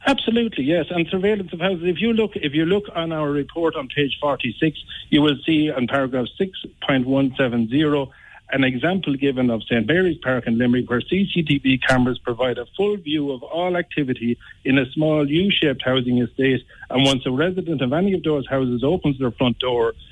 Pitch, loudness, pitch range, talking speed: 145 Hz, -21 LUFS, 130-170 Hz, 190 wpm